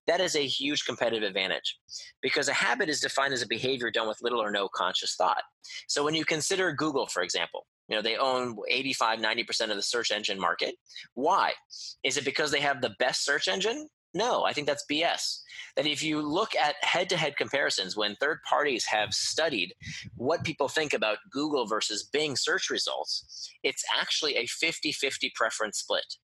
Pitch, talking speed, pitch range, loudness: 145 Hz, 190 wpm, 130-165 Hz, -28 LUFS